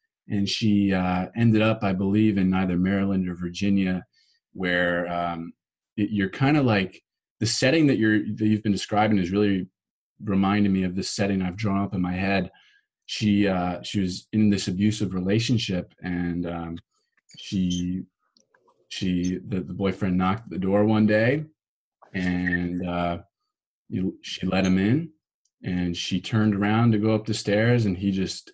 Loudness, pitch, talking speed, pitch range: -24 LUFS, 100 Hz, 165 wpm, 90-105 Hz